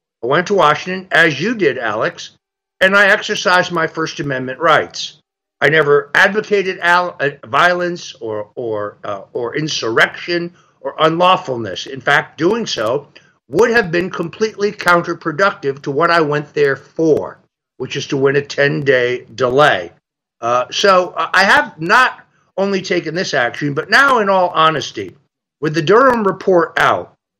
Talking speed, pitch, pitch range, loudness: 145 wpm, 170 Hz, 145-190 Hz, -15 LUFS